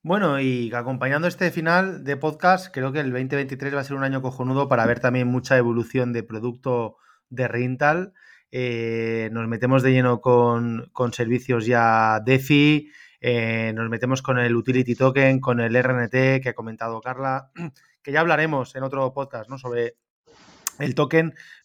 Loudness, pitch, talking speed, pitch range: -22 LUFS, 130 Hz, 165 wpm, 120-140 Hz